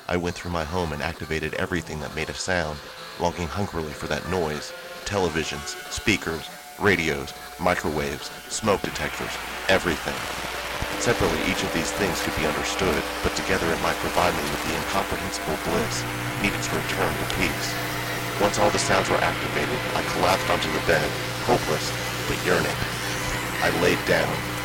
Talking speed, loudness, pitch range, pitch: 155 wpm, -25 LUFS, 75-90 Hz, 80 Hz